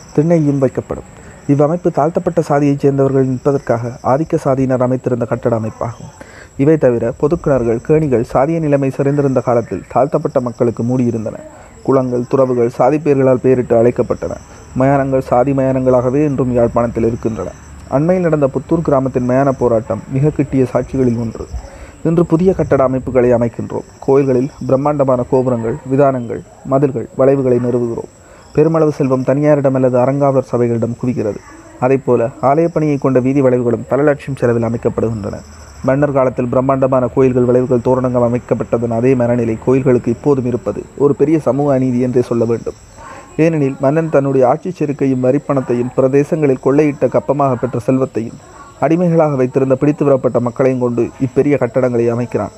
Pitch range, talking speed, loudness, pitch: 120-140 Hz, 125 wpm, -14 LUFS, 130 Hz